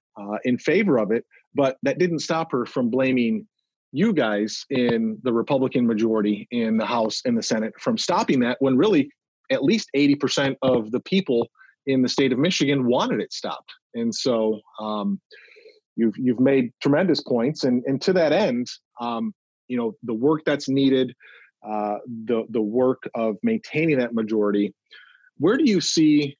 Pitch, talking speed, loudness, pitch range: 130 Hz, 175 wpm, -22 LUFS, 115-155 Hz